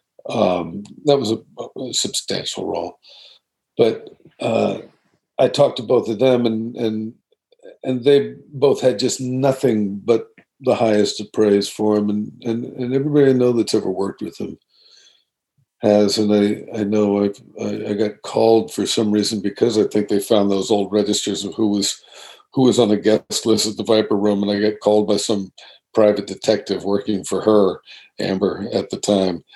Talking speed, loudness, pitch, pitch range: 180 wpm, -19 LUFS, 110 Hz, 105-120 Hz